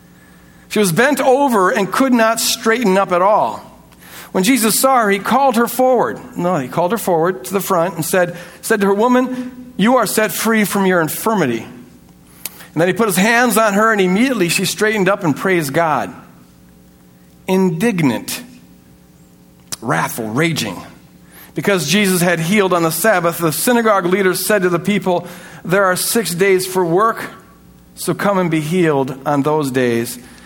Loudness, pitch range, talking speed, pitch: -15 LUFS, 160-220 Hz, 170 wpm, 185 Hz